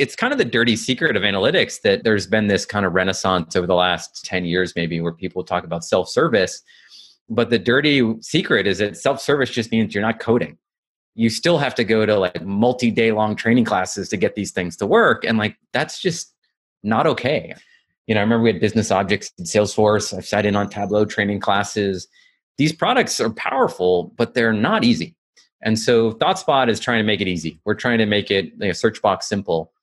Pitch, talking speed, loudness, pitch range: 105 Hz, 220 wpm, -19 LUFS, 95-115 Hz